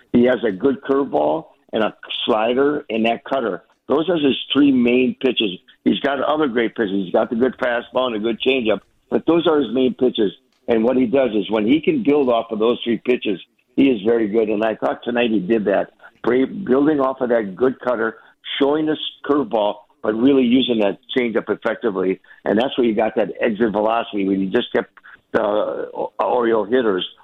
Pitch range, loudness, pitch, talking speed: 110-135 Hz, -19 LUFS, 120 Hz, 205 wpm